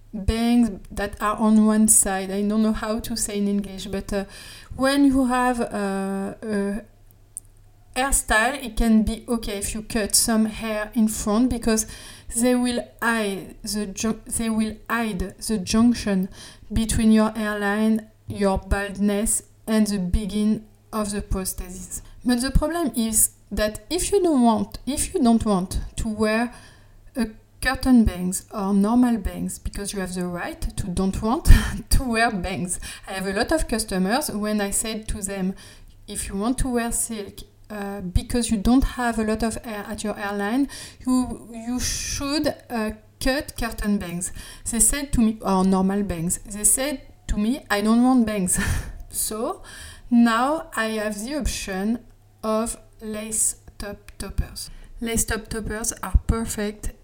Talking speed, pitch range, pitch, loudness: 160 wpm, 200-230 Hz, 215 Hz, -23 LUFS